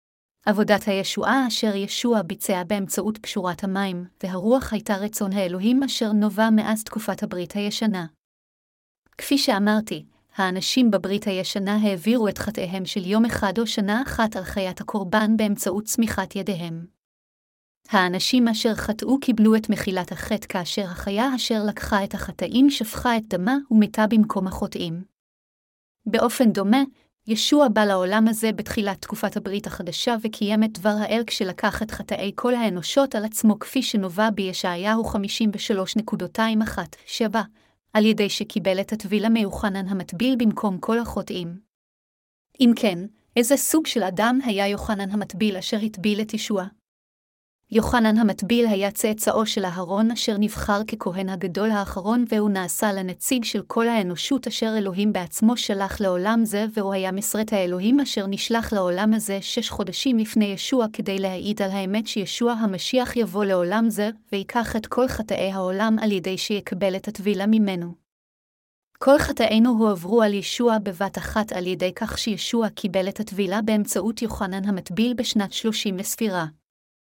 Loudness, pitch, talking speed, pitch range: -23 LUFS, 210 Hz, 140 wpm, 195-225 Hz